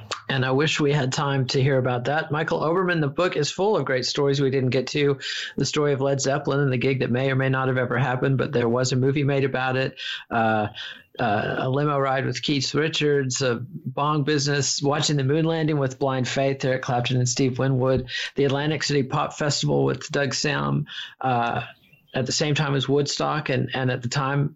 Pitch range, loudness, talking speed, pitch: 130-145 Hz, -23 LUFS, 220 wpm, 135 Hz